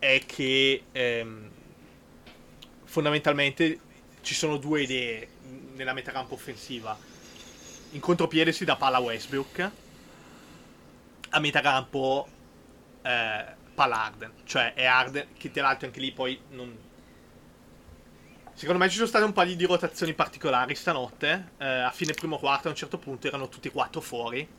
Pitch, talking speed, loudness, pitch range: 135 Hz, 140 wpm, -27 LUFS, 130-160 Hz